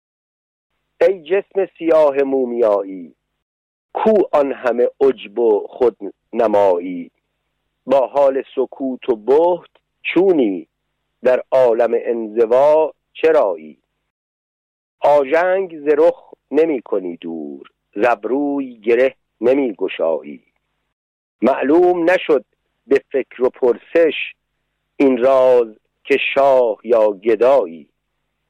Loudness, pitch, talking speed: -16 LUFS, 170 Hz, 85 wpm